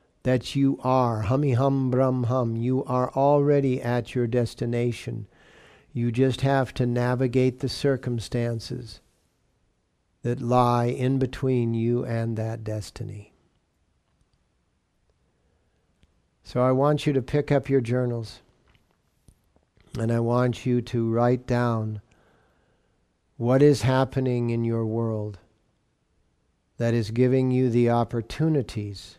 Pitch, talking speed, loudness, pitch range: 120 Hz, 115 wpm, -24 LUFS, 110-130 Hz